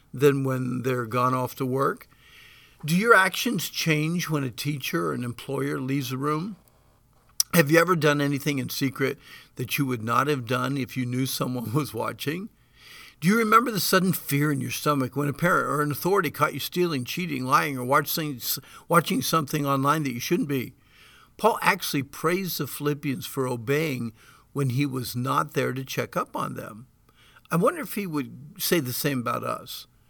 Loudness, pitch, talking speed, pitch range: -25 LUFS, 140 Hz, 185 wpm, 130-160 Hz